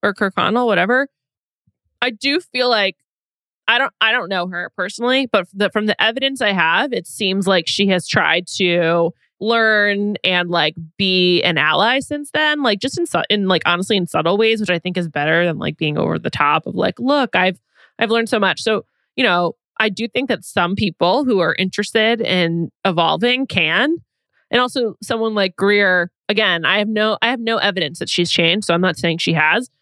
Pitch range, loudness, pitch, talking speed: 175-230 Hz, -17 LUFS, 205 Hz, 210 wpm